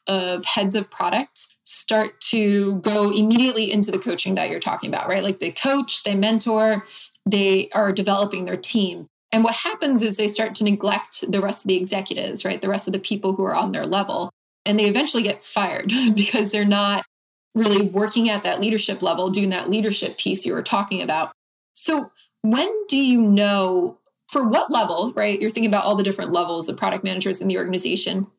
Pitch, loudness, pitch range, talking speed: 205 Hz, -21 LUFS, 195-220 Hz, 200 wpm